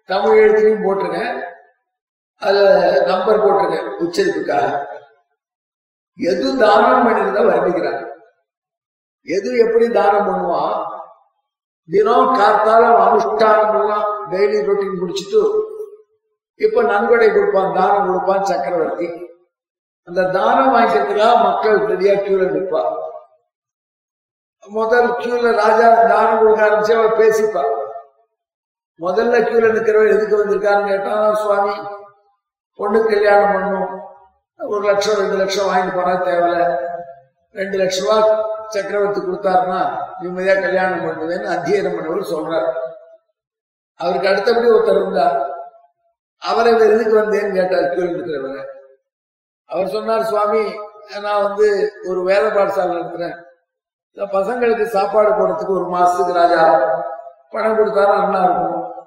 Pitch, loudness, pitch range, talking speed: 205 Hz, -16 LUFS, 185-225 Hz, 100 wpm